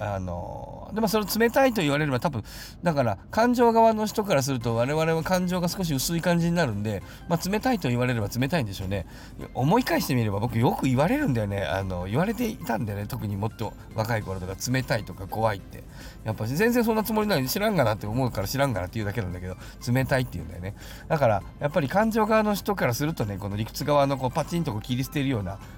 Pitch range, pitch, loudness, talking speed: 105-175 Hz, 130 Hz, -26 LUFS, 485 characters per minute